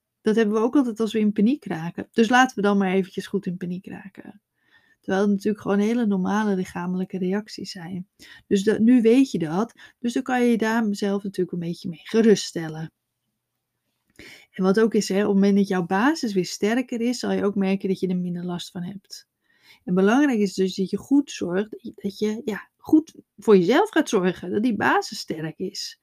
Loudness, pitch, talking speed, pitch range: -23 LUFS, 200 Hz, 210 wpm, 185-225 Hz